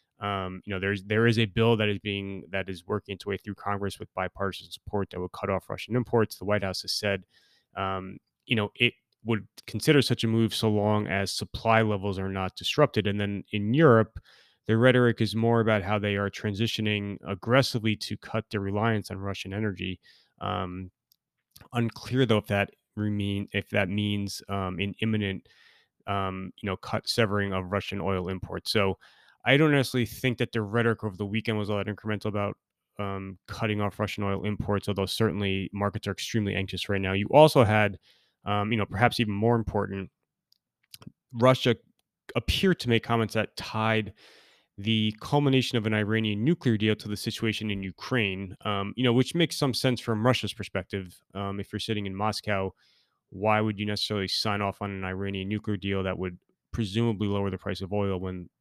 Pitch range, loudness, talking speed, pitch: 100-115 Hz, -27 LUFS, 190 wpm, 105 Hz